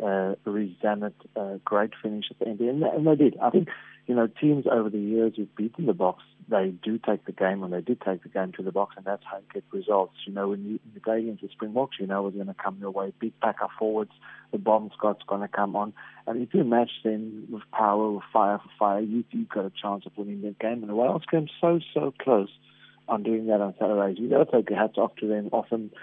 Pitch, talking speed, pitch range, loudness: 105 Hz, 260 wpm, 100-115 Hz, -27 LUFS